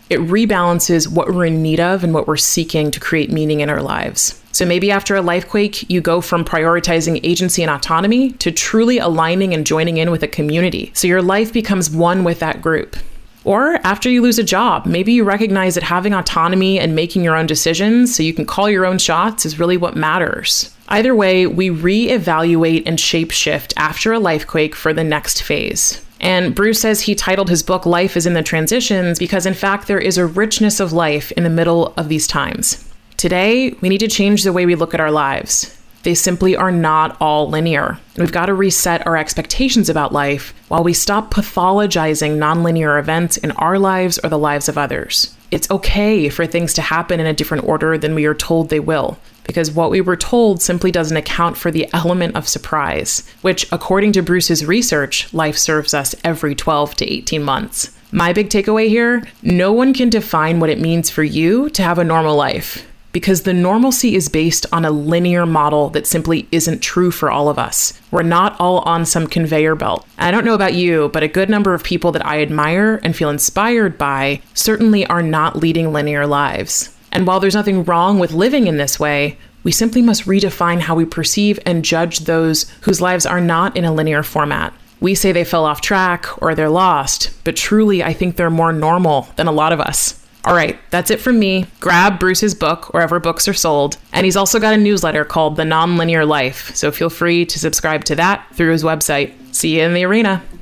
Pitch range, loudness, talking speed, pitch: 160-190 Hz, -15 LUFS, 210 wpm, 170 Hz